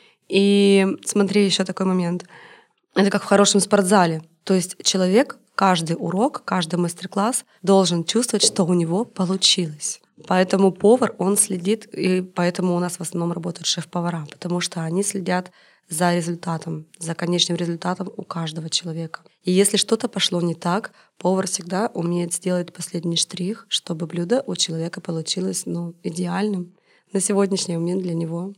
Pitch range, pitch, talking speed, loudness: 175-200 Hz, 185 Hz, 150 wpm, -21 LUFS